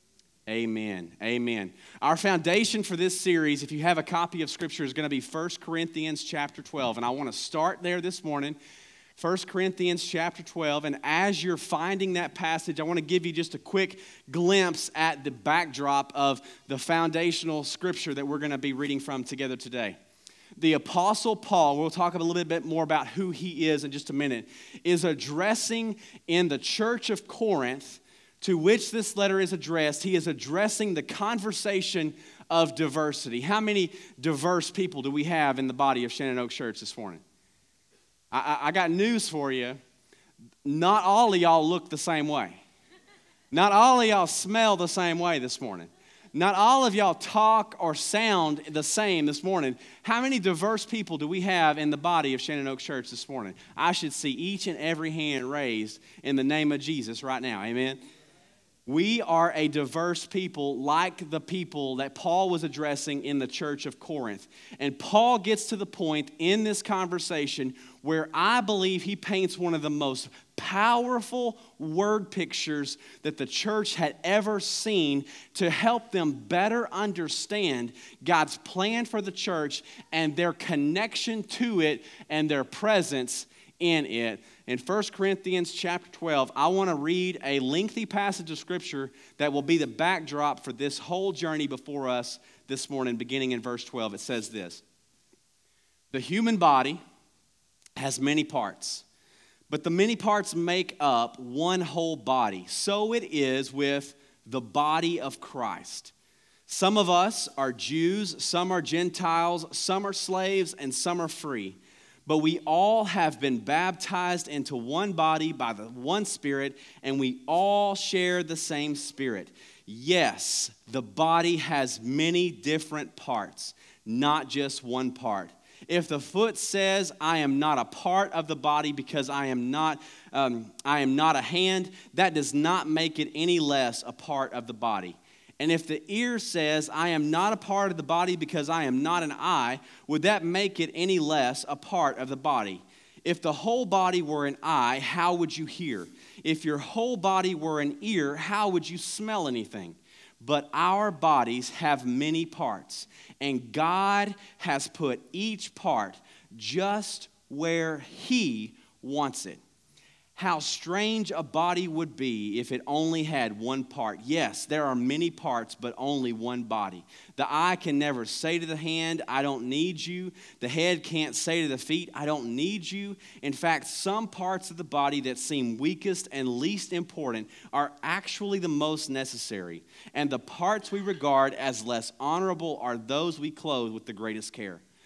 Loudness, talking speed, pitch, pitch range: -28 LUFS, 175 wpm, 160 Hz, 140-185 Hz